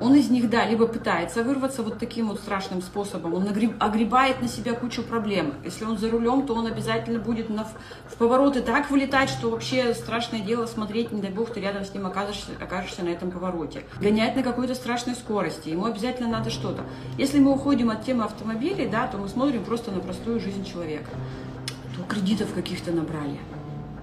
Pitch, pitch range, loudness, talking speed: 225 Hz, 195-240 Hz, -26 LUFS, 185 wpm